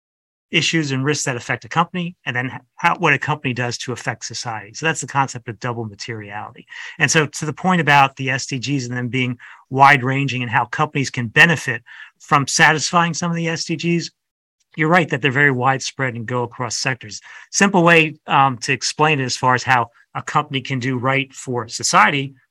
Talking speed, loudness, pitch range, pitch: 200 wpm, -18 LUFS, 125-155 Hz, 135 Hz